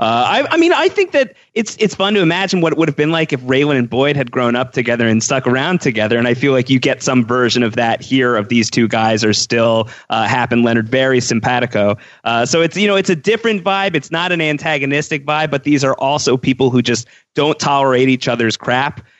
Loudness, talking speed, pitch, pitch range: -14 LUFS, 245 wpm, 130 Hz, 120-160 Hz